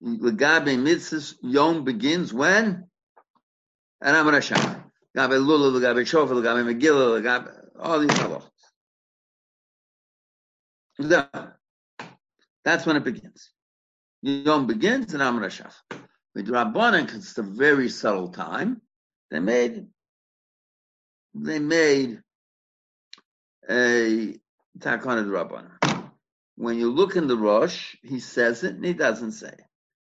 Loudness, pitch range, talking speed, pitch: -22 LUFS, 120-170 Hz, 120 wpm, 135 Hz